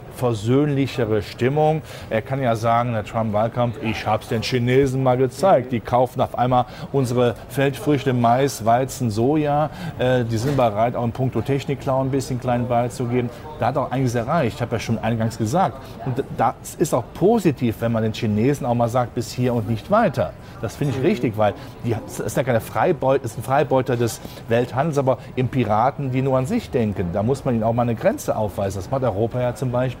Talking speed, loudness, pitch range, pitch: 210 wpm, -21 LUFS, 115-135 Hz, 125 Hz